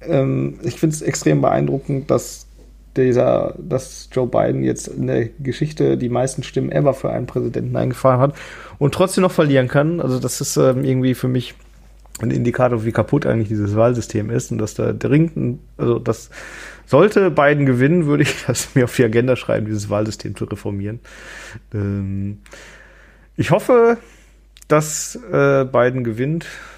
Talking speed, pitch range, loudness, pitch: 150 wpm, 110-145 Hz, -18 LUFS, 125 Hz